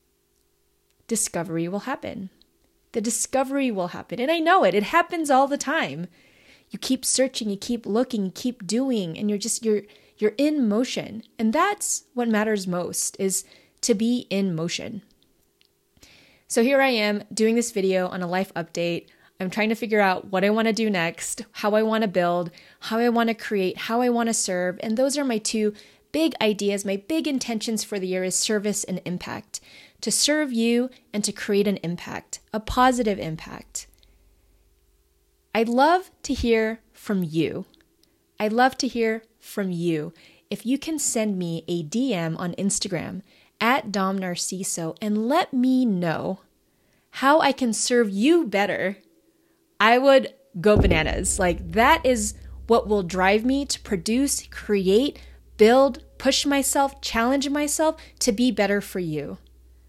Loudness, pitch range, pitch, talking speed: -23 LUFS, 190-255 Hz, 220 Hz, 165 wpm